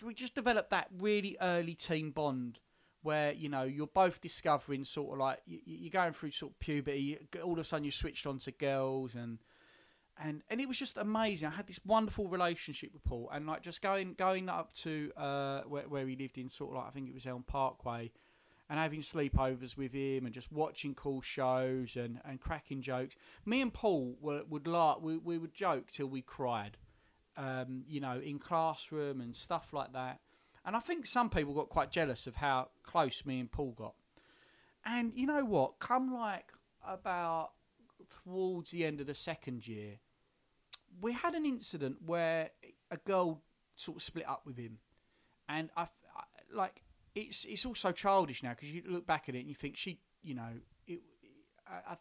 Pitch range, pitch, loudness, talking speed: 130-185 Hz, 150 Hz, -38 LUFS, 195 wpm